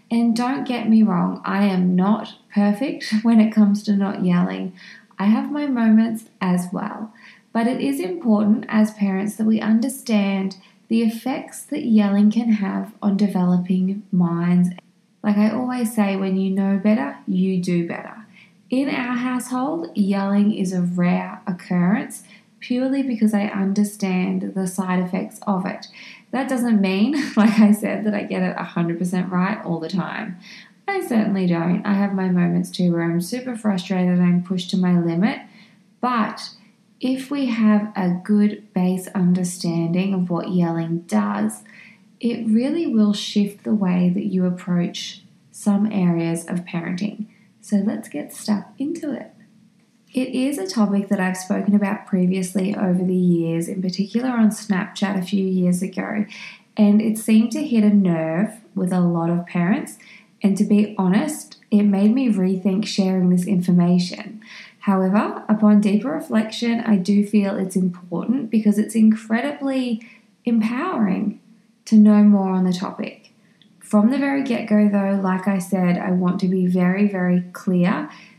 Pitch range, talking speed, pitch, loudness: 185-220 Hz, 160 wpm, 205 Hz, -20 LUFS